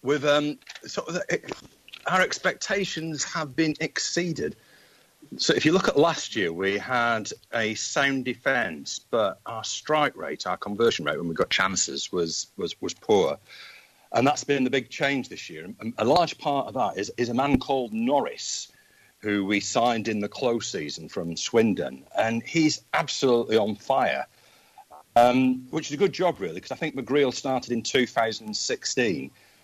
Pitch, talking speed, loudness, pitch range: 130 Hz, 175 wpm, -25 LUFS, 115-155 Hz